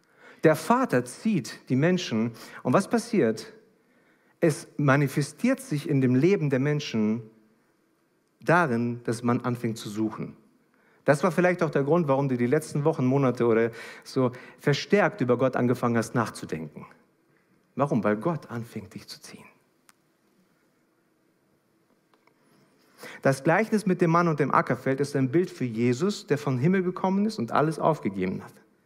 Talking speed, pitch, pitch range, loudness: 150 wpm, 140 Hz, 120-170 Hz, -26 LUFS